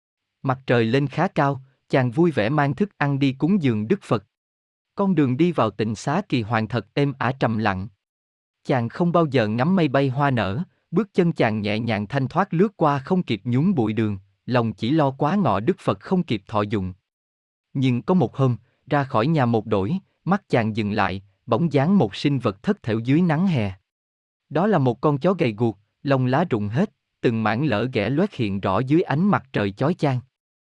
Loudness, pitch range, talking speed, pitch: -22 LUFS, 110-160 Hz, 215 wpm, 130 Hz